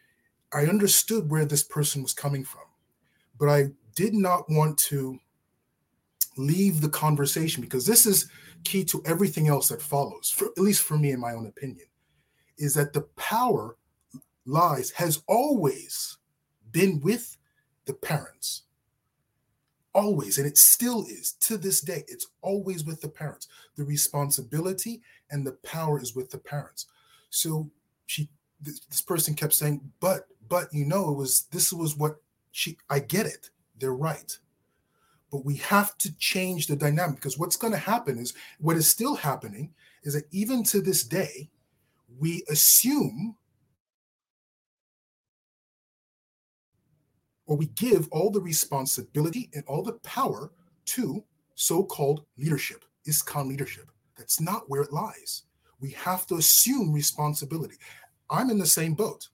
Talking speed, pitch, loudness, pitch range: 145 wpm, 155 Hz, -25 LUFS, 145-185 Hz